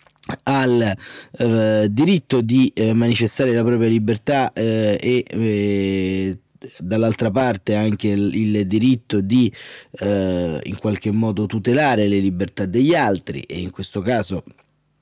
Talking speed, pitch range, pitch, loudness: 130 wpm, 100-120 Hz, 110 Hz, -19 LUFS